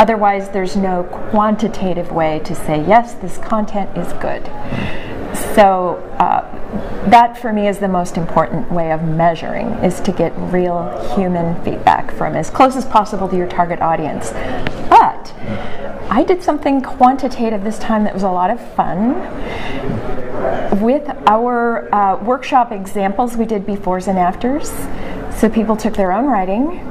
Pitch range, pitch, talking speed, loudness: 180-230 Hz, 205 Hz, 150 wpm, -16 LUFS